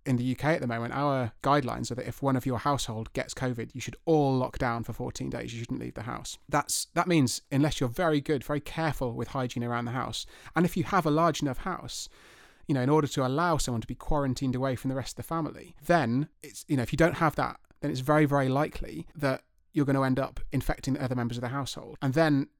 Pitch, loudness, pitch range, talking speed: 135 Hz, -29 LUFS, 125-150 Hz, 260 wpm